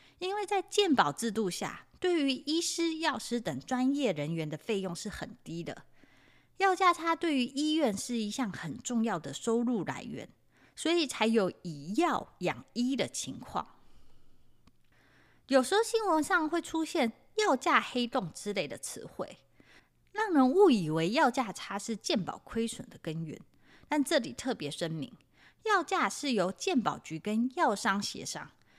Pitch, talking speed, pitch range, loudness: 250 Hz, 225 characters per minute, 200-320 Hz, -31 LUFS